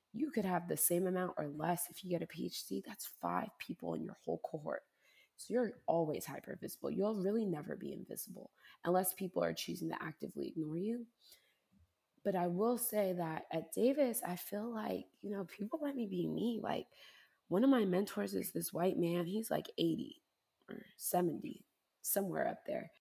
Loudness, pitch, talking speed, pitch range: -38 LUFS, 195 Hz, 190 wpm, 175-230 Hz